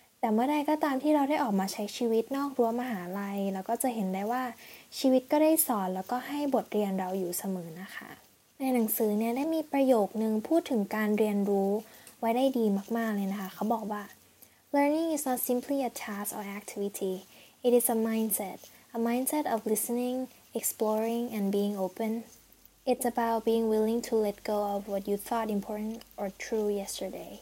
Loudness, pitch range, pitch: -30 LUFS, 205-250 Hz, 225 Hz